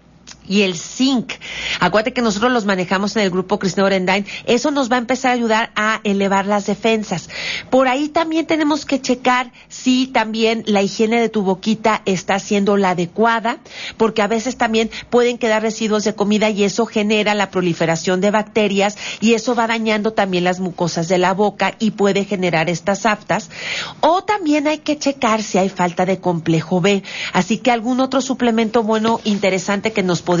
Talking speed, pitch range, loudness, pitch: 185 wpm, 195-235 Hz, -17 LUFS, 215 Hz